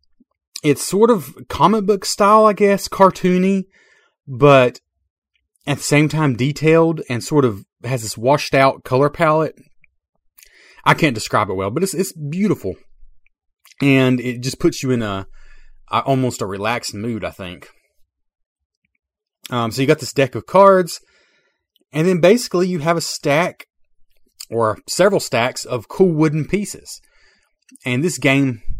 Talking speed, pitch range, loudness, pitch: 150 wpm, 125-180 Hz, -17 LUFS, 145 Hz